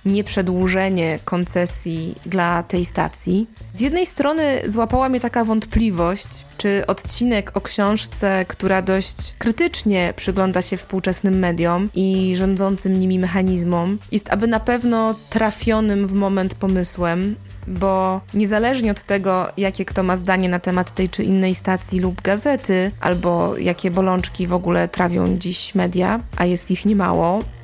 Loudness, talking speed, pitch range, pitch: -20 LUFS, 135 wpm, 180-205 Hz, 190 Hz